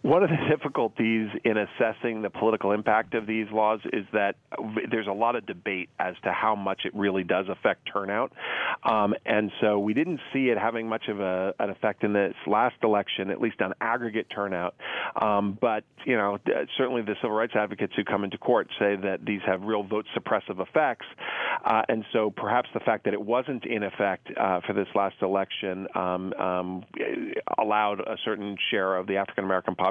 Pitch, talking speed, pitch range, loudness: 105 Hz, 195 wpm, 95-110 Hz, -27 LUFS